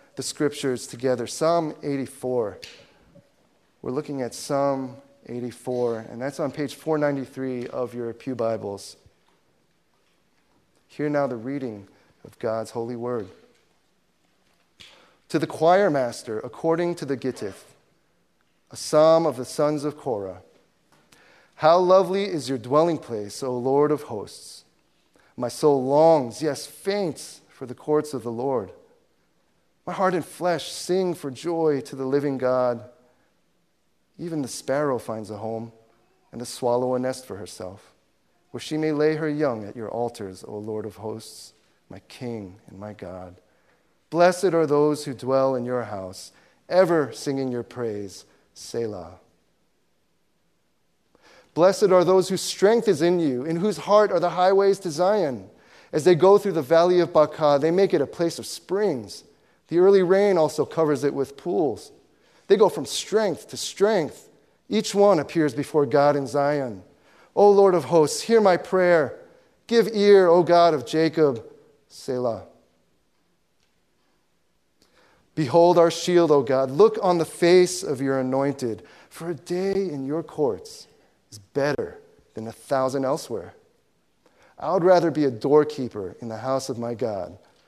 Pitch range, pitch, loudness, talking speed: 125-175 Hz, 145 Hz, -23 LUFS, 150 wpm